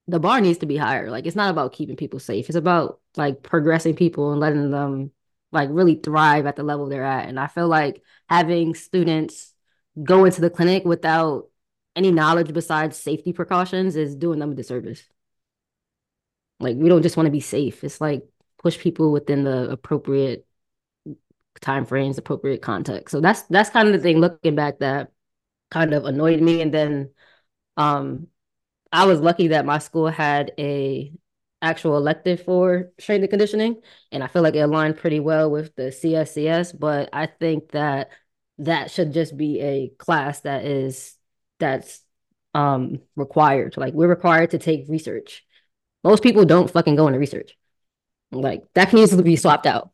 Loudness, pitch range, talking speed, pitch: -20 LUFS, 145-170 Hz, 175 wpm, 155 Hz